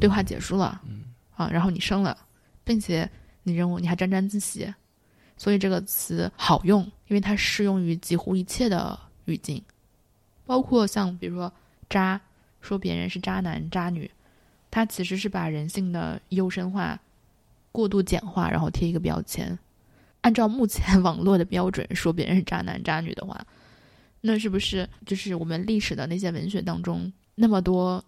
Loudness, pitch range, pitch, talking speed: -26 LUFS, 170-200 Hz, 185 Hz, 250 characters per minute